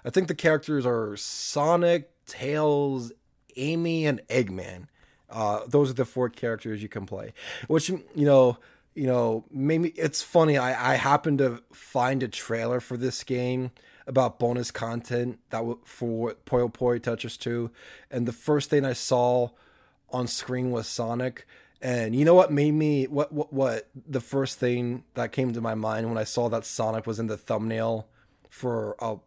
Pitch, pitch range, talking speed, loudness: 125 Hz, 115-140 Hz, 170 wpm, -26 LUFS